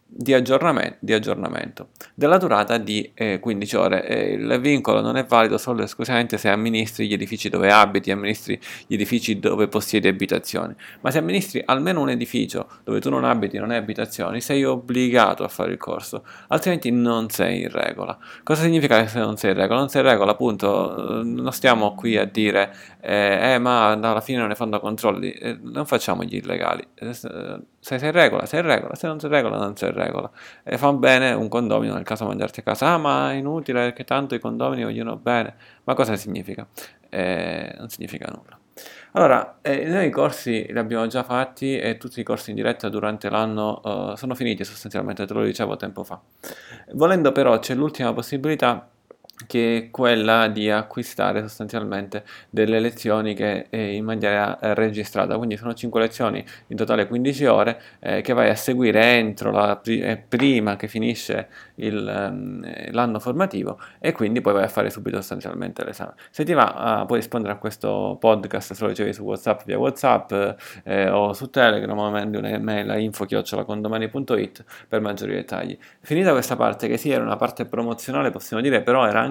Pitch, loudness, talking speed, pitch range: 115 Hz, -22 LUFS, 185 wpm, 105-125 Hz